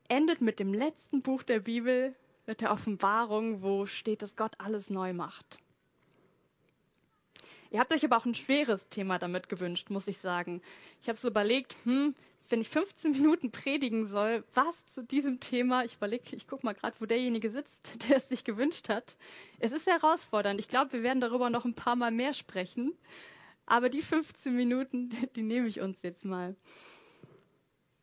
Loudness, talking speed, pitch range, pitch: -32 LUFS, 180 wpm, 205-265 Hz, 235 Hz